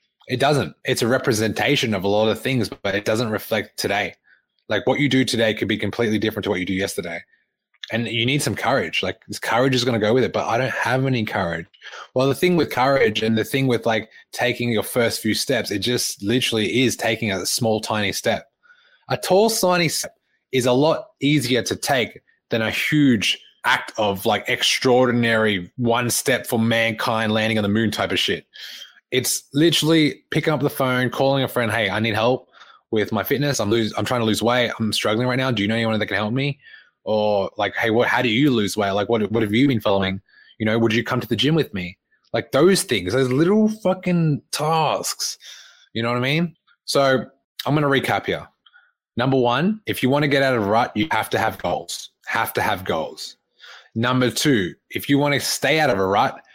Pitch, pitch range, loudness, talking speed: 120 Hz, 110-140 Hz, -20 LUFS, 225 wpm